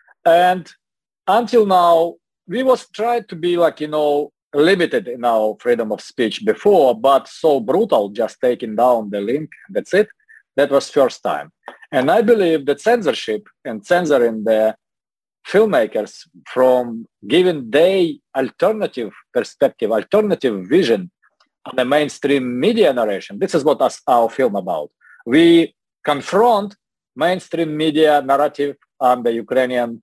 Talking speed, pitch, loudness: 135 wpm, 155 Hz, -17 LUFS